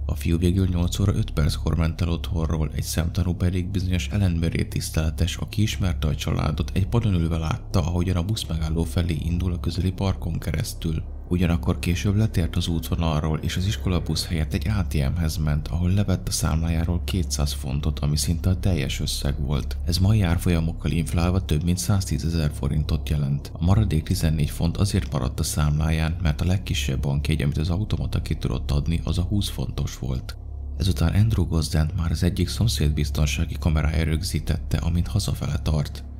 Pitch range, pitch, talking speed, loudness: 75-90 Hz, 85 Hz, 170 wpm, -24 LUFS